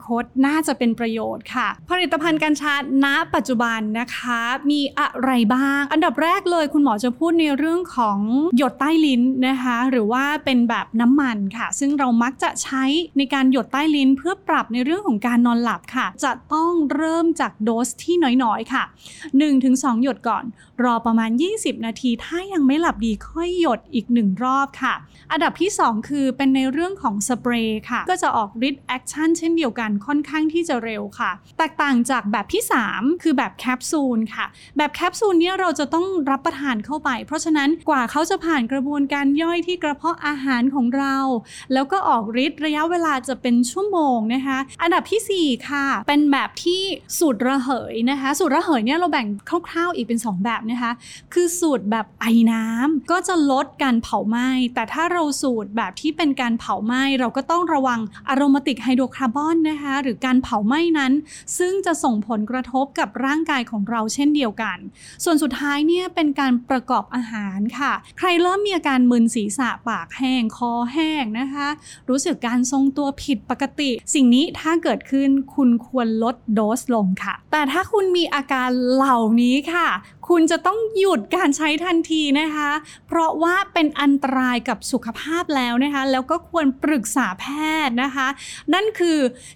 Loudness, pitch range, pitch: -20 LUFS, 245-315 Hz, 275 Hz